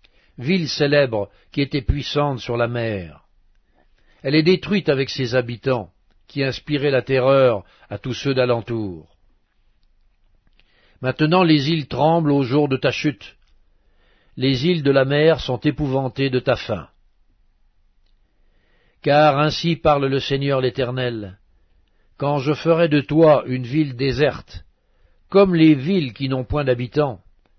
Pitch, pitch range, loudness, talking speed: 135 Hz, 105-150 Hz, -19 LUFS, 135 wpm